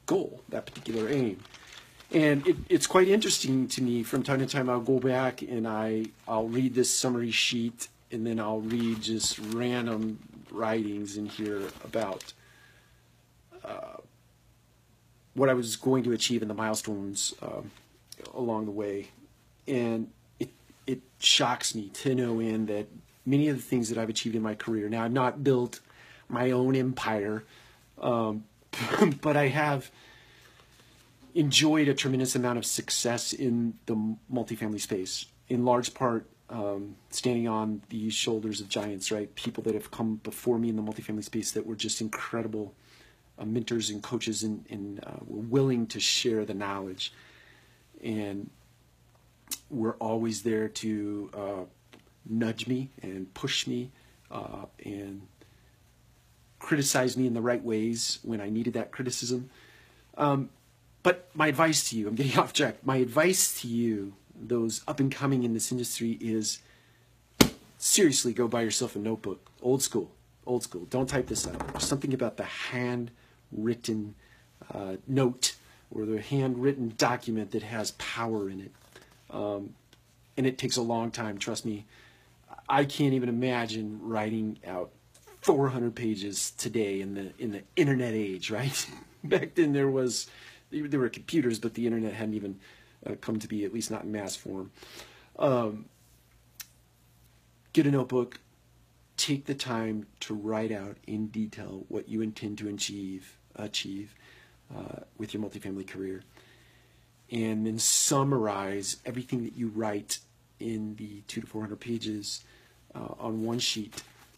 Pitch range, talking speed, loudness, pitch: 105-125 Hz, 150 wpm, -30 LUFS, 115 Hz